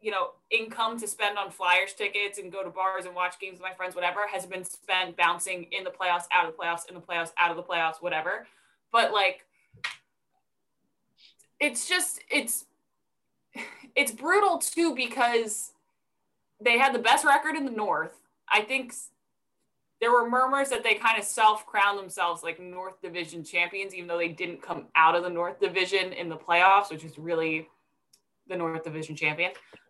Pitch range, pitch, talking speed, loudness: 175-230 Hz, 190 Hz, 180 wpm, -26 LUFS